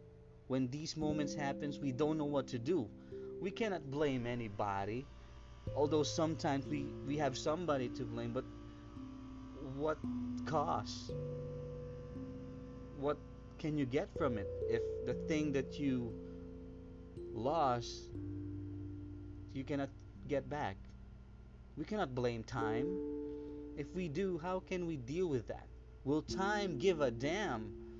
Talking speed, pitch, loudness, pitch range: 125 wpm, 130 Hz, -40 LUFS, 115-150 Hz